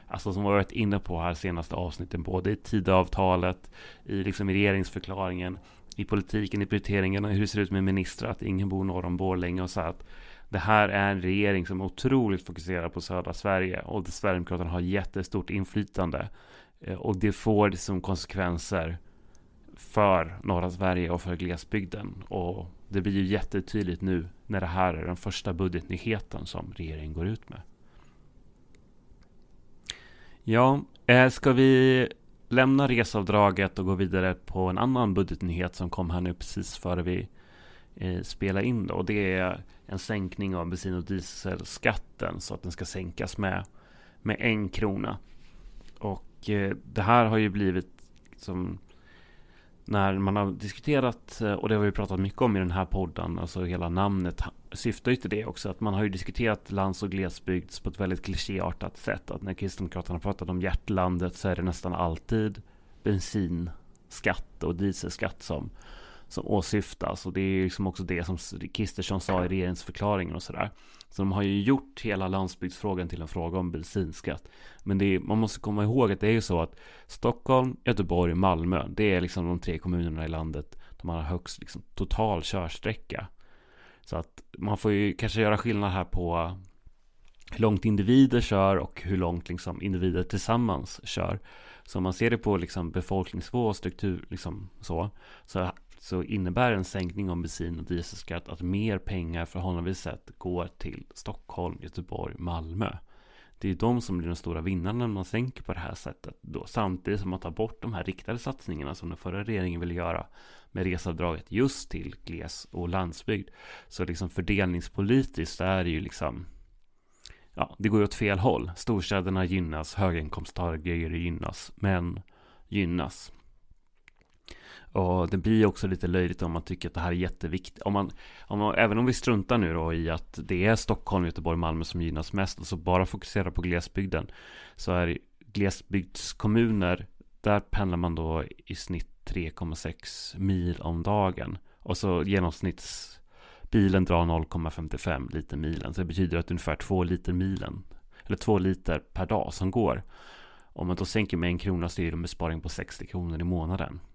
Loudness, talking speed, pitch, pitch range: -29 LUFS, 175 wpm, 95 Hz, 90-100 Hz